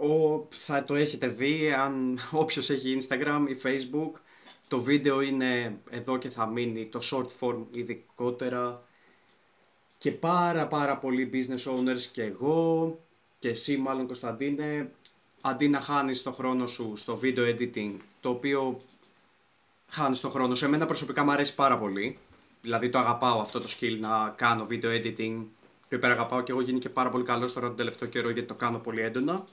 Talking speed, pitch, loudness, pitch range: 170 wpm, 130 Hz, -29 LUFS, 120-140 Hz